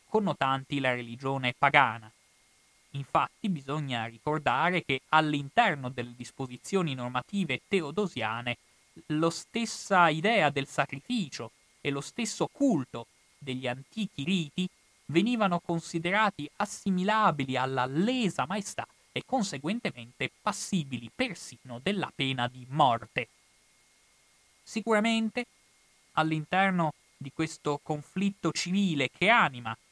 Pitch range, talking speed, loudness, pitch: 130-195 Hz, 95 wpm, -29 LUFS, 155 Hz